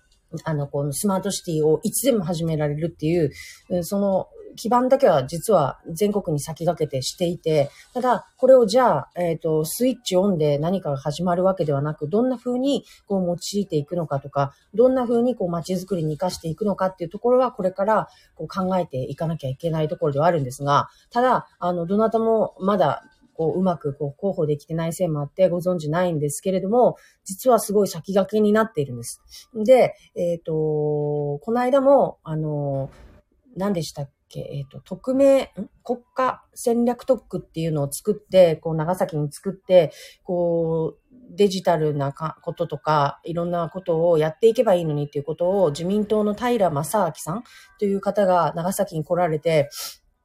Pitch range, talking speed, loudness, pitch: 155-205 Hz, 365 characters per minute, -22 LUFS, 175 Hz